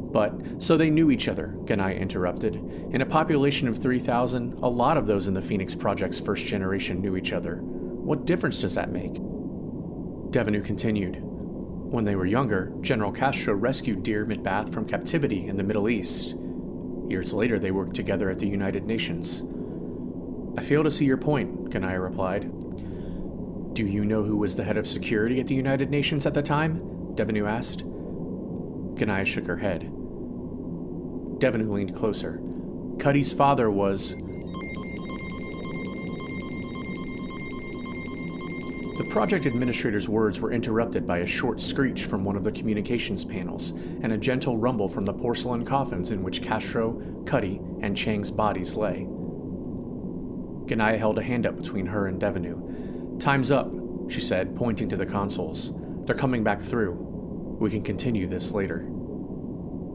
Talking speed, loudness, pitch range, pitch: 150 wpm, -27 LUFS, 90-120 Hz, 100 Hz